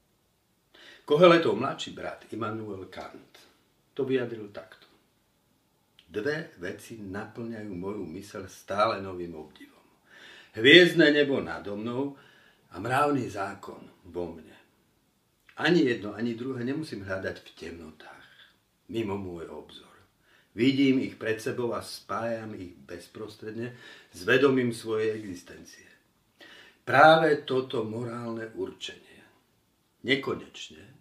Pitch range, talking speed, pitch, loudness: 100-130 Hz, 100 wpm, 115 Hz, -26 LUFS